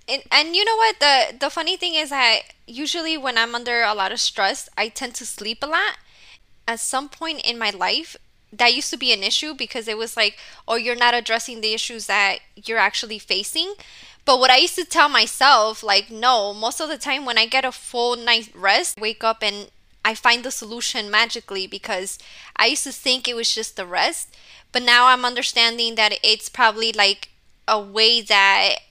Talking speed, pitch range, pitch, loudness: 210 wpm, 220-270 Hz, 235 Hz, -19 LUFS